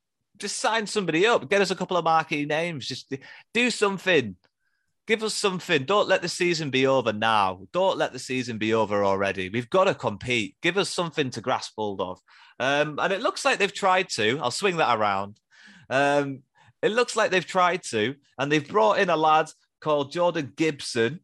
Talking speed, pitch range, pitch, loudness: 200 wpm, 125-190 Hz, 155 Hz, -24 LUFS